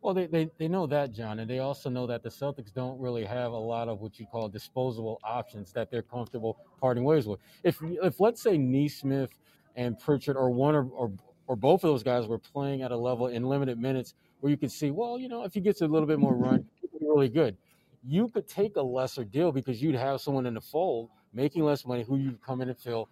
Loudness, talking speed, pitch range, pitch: -30 LUFS, 245 wpm, 120-150 Hz, 130 Hz